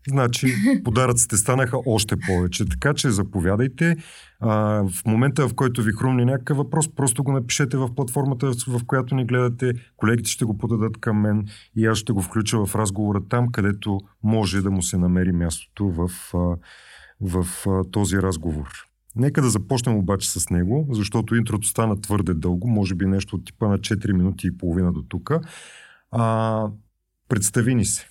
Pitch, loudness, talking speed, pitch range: 110 Hz, -22 LUFS, 160 wpm, 95-125 Hz